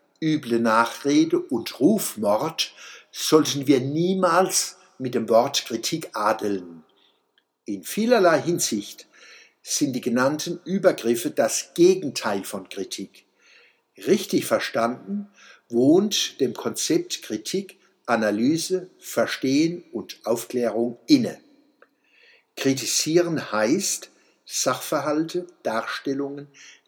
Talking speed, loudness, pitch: 85 wpm, -23 LUFS, 160 Hz